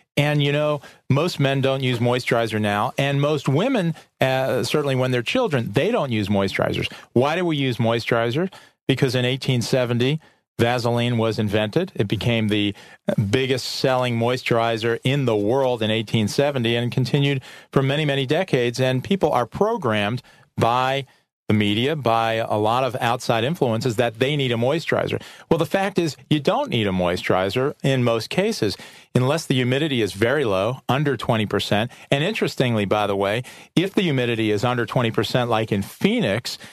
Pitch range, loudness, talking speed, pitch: 115-140 Hz, -21 LUFS, 165 wpm, 125 Hz